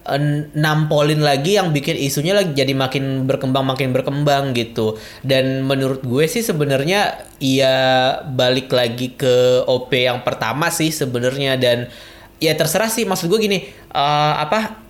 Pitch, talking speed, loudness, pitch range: 135 Hz, 150 wpm, -17 LUFS, 130-155 Hz